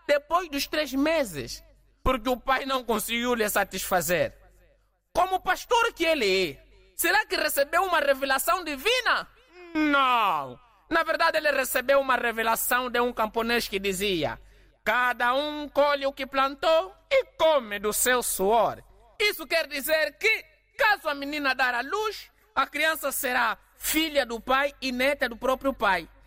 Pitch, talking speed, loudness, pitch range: 275 Hz, 150 wpm, -25 LUFS, 245-320 Hz